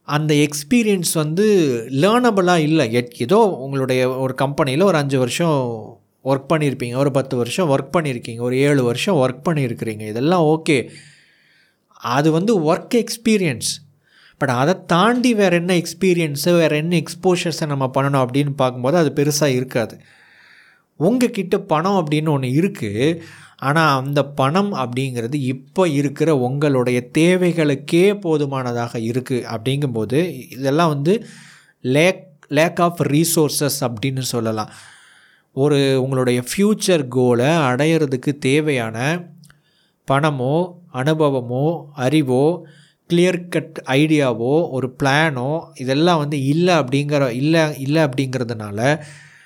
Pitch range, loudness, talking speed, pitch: 130-170 Hz, -18 LUFS, 110 wpm, 150 Hz